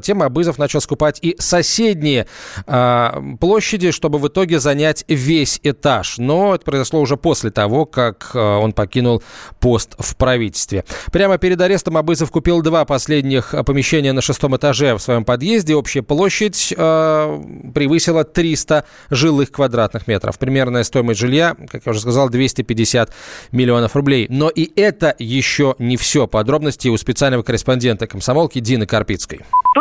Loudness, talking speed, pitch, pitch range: -16 LUFS, 145 wpm, 140 Hz, 120-160 Hz